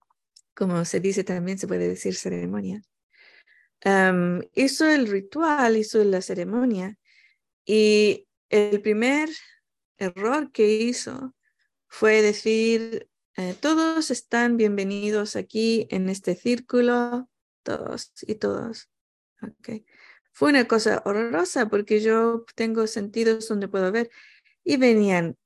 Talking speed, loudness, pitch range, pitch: 115 wpm, -23 LUFS, 195-245 Hz, 220 Hz